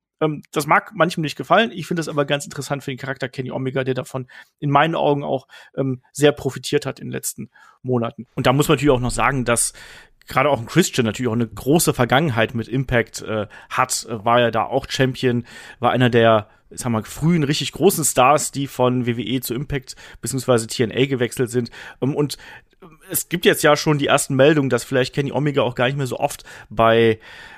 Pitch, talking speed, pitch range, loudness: 130 Hz, 205 wpm, 120-145 Hz, -20 LUFS